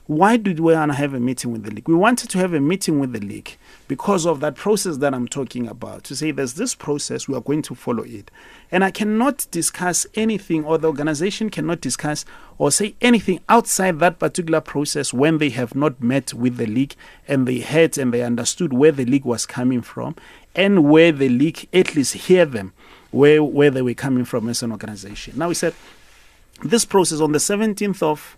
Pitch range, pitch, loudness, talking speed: 130-180 Hz, 150 Hz, -19 LUFS, 210 wpm